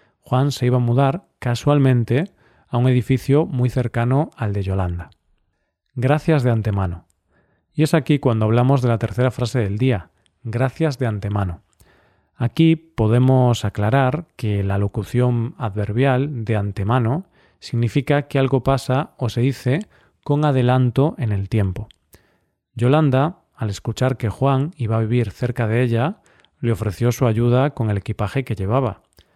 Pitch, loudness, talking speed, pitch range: 125 Hz, -20 LUFS, 145 wpm, 110-135 Hz